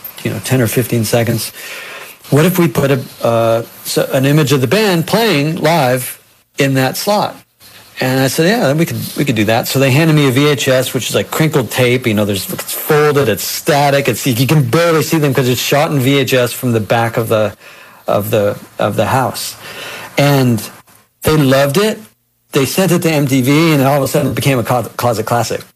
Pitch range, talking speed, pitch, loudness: 120-150 Hz, 210 wpm, 135 Hz, -13 LUFS